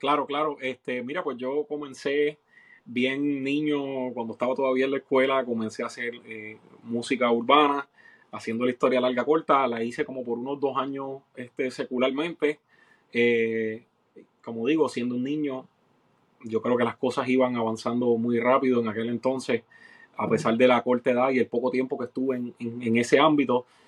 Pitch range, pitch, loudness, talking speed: 120-135 Hz, 125 Hz, -26 LUFS, 175 wpm